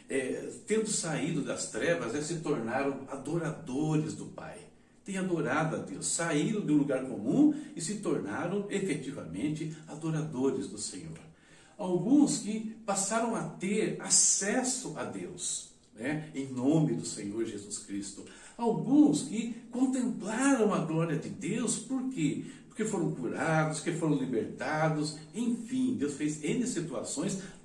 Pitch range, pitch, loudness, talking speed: 150-220 Hz, 170 Hz, -31 LUFS, 130 wpm